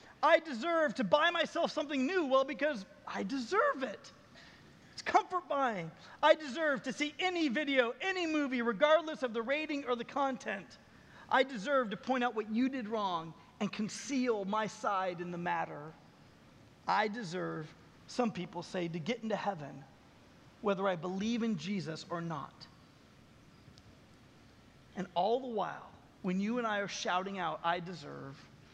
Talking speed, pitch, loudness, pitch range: 155 wpm, 235 Hz, -34 LUFS, 185-280 Hz